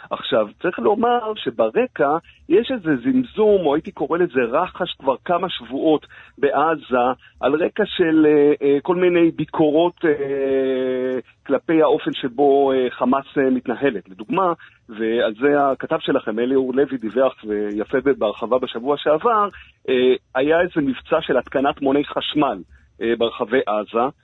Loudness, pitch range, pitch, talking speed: -20 LUFS, 130-170 Hz, 140 Hz, 135 wpm